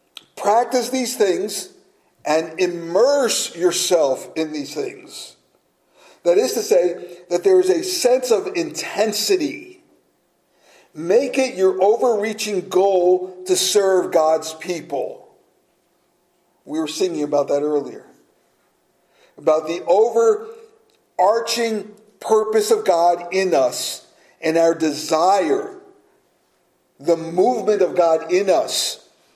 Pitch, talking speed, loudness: 200 Hz, 105 wpm, -19 LUFS